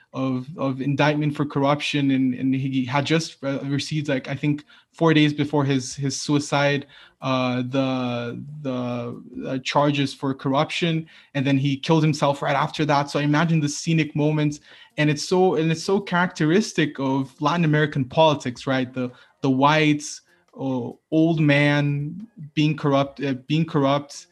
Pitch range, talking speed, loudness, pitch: 135-155 Hz, 160 wpm, -22 LUFS, 145 Hz